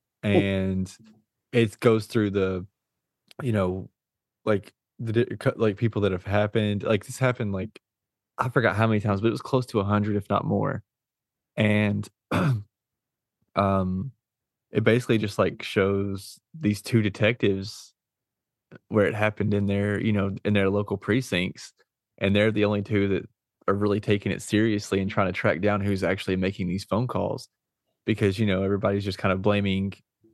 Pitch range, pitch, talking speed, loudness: 100-110 Hz, 105 Hz, 165 wpm, -25 LUFS